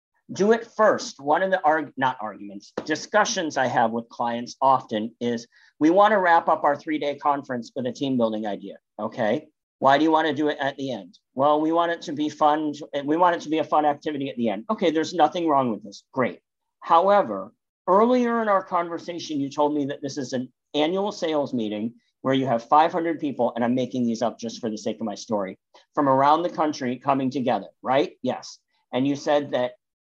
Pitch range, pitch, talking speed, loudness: 130-165 Hz, 145 Hz, 220 wpm, -23 LUFS